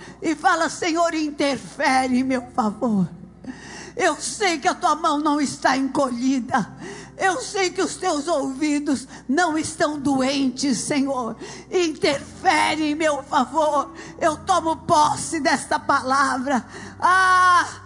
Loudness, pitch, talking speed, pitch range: -21 LUFS, 295 Hz, 120 wpm, 265-335 Hz